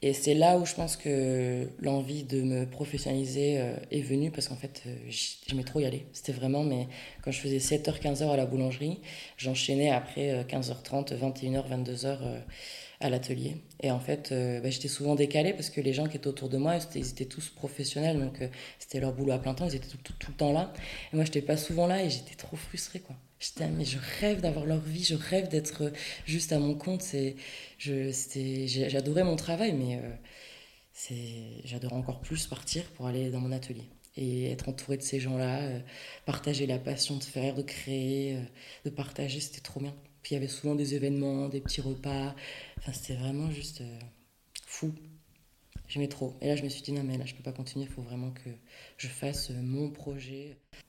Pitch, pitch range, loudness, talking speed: 140 Hz, 130-145 Hz, -33 LUFS, 205 wpm